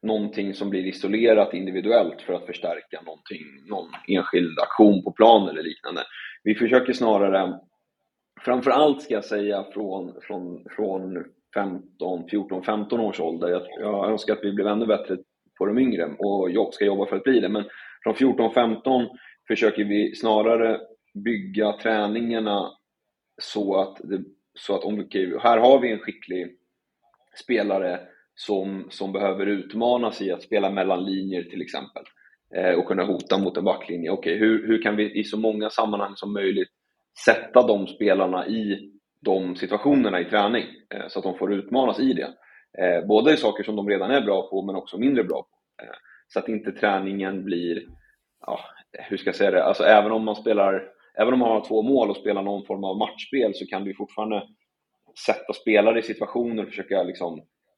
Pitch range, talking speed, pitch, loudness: 95-110 Hz, 180 wpm, 105 Hz, -23 LUFS